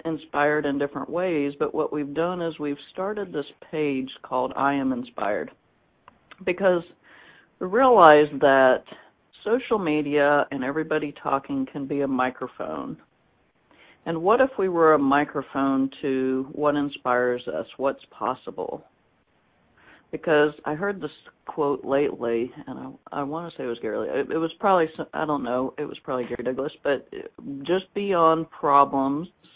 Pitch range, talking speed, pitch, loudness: 135-165 Hz, 150 wpm, 145 Hz, -24 LUFS